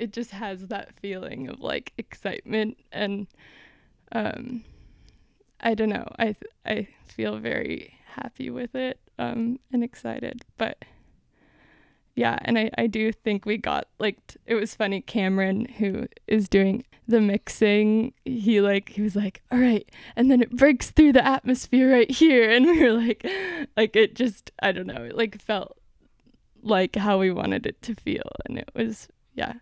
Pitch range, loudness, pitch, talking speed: 210-245 Hz, -24 LUFS, 225 Hz, 170 wpm